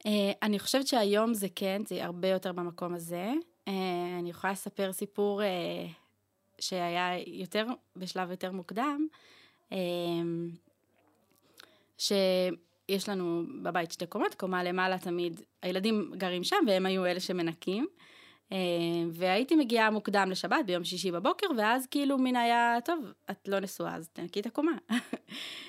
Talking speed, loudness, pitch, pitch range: 140 wpm, -32 LUFS, 190 Hz, 180-220 Hz